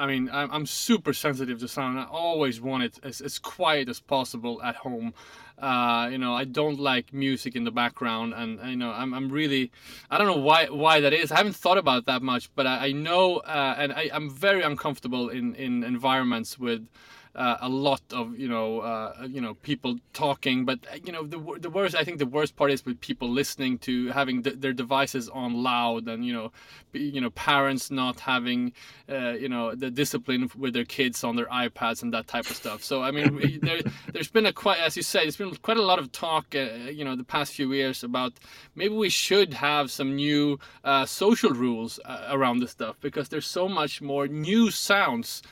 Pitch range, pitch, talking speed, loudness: 125-155 Hz, 135 Hz, 220 wpm, -26 LUFS